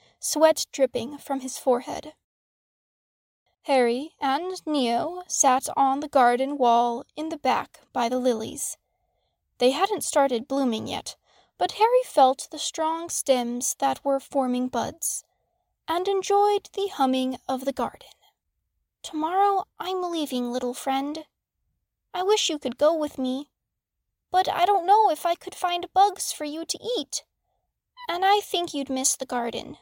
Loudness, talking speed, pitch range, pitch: -25 LUFS, 145 wpm, 260-360 Hz, 290 Hz